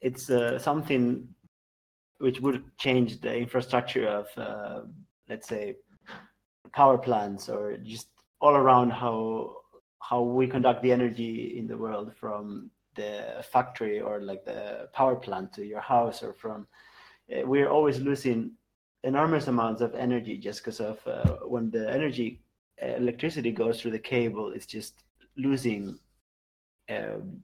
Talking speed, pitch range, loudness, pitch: 140 wpm, 110-130 Hz, -28 LUFS, 120 Hz